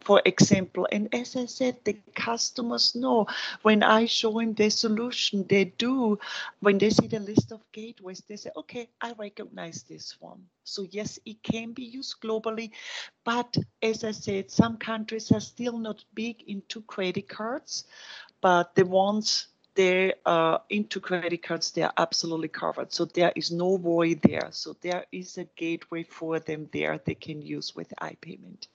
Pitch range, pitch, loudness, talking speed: 180-225 Hz, 210 Hz, -27 LUFS, 175 wpm